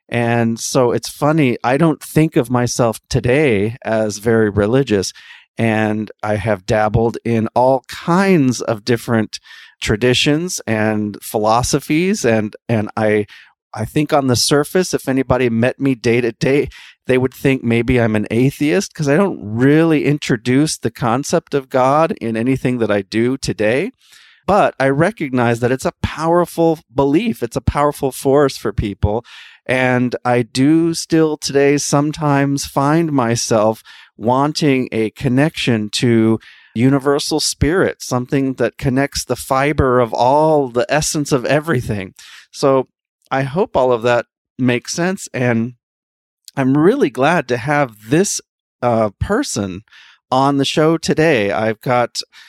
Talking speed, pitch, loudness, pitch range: 140 wpm, 130 Hz, -16 LUFS, 115-145 Hz